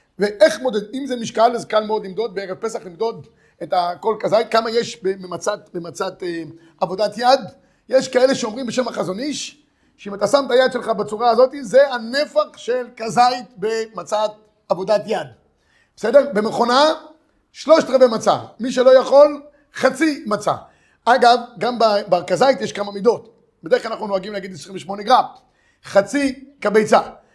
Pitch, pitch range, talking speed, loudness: 225 Hz, 205-260 Hz, 145 wpm, -18 LUFS